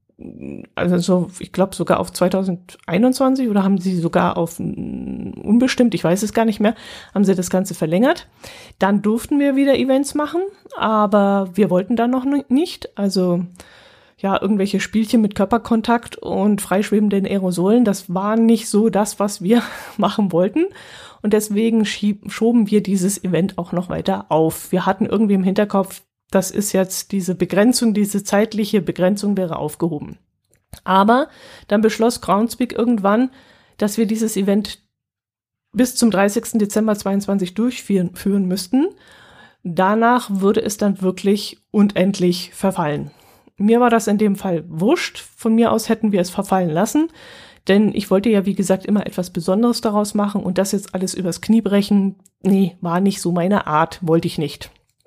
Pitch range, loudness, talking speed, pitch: 185-225 Hz, -18 LUFS, 160 wpm, 200 Hz